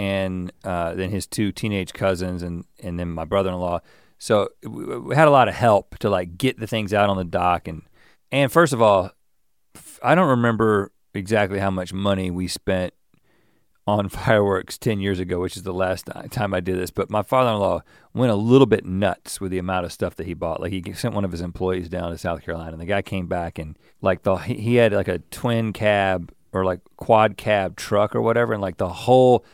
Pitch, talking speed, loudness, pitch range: 95 Hz, 220 wpm, -22 LUFS, 90-110 Hz